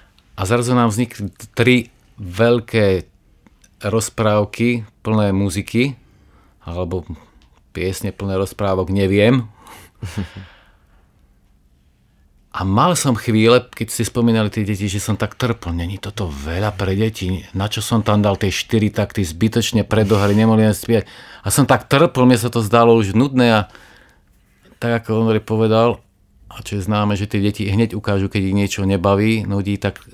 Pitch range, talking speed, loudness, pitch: 100-115 Hz, 145 wpm, -17 LUFS, 105 Hz